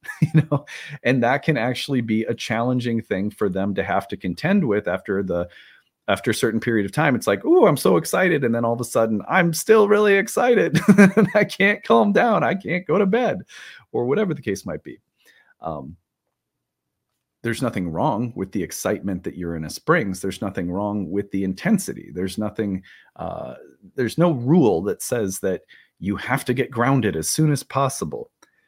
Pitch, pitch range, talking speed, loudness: 120 Hz, 100-160 Hz, 195 wpm, -21 LUFS